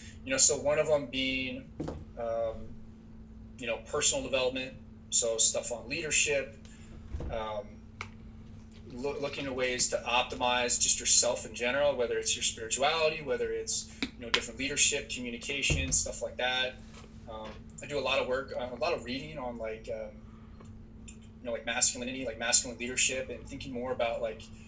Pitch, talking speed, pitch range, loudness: 115 Hz, 165 wpm, 110-130 Hz, -29 LUFS